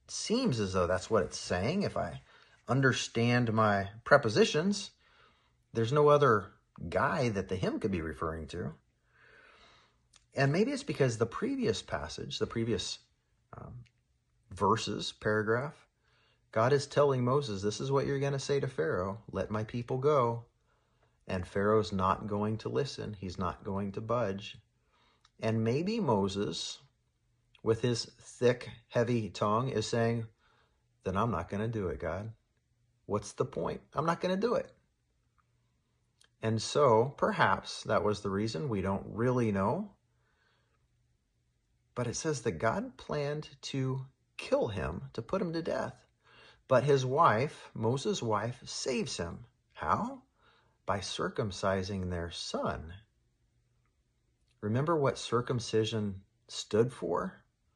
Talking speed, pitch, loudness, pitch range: 135 wpm, 115 Hz, -32 LUFS, 105-125 Hz